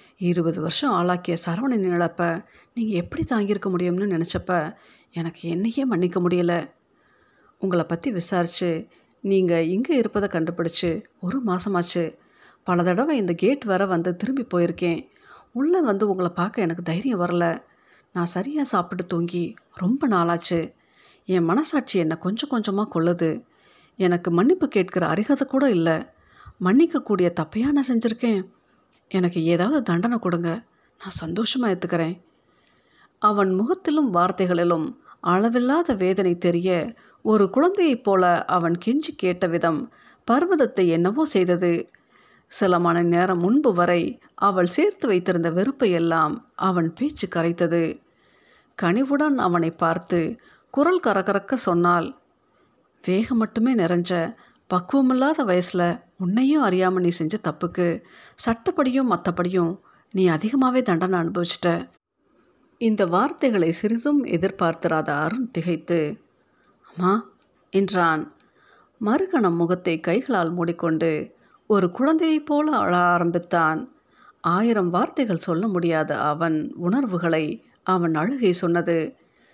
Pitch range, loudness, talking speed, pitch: 170-240 Hz, -22 LUFS, 110 wpm, 180 Hz